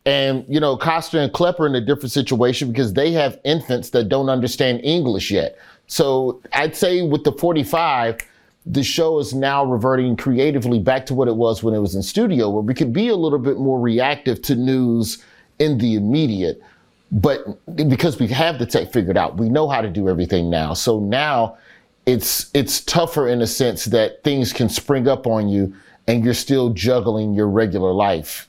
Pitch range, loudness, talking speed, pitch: 115-145 Hz, -19 LUFS, 195 wpm, 130 Hz